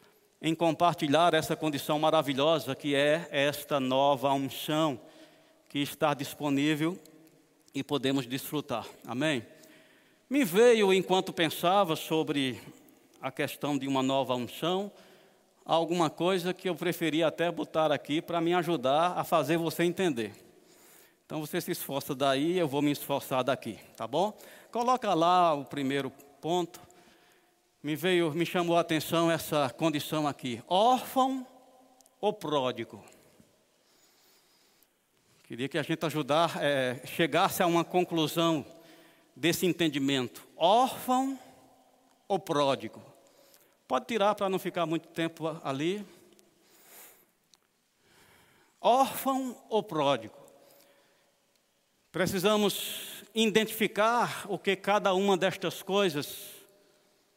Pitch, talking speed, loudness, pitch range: 165 Hz, 110 wpm, -29 LUFS, 145-195 Hz